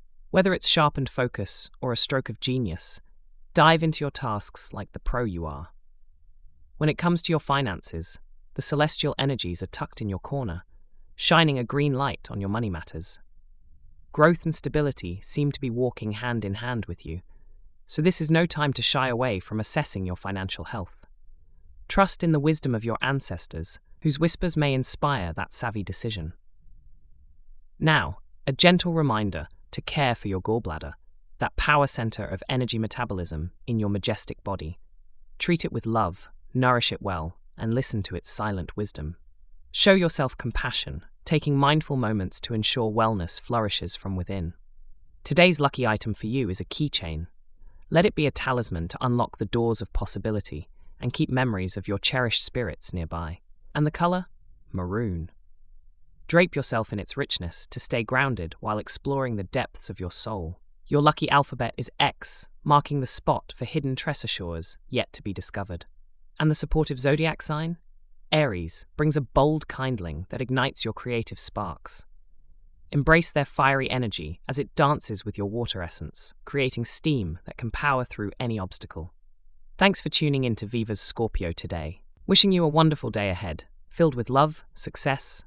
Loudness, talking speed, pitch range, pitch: -23 LUFS, 165 wpm, 85-140 Hz, 110 Hz